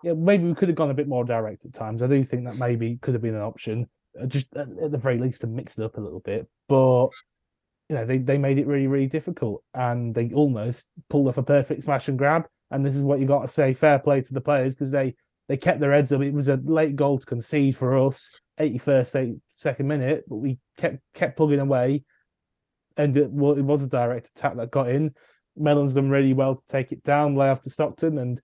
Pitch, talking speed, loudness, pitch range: 140 Hz, 245 wpm, -24 LUFS, 130-145 Hz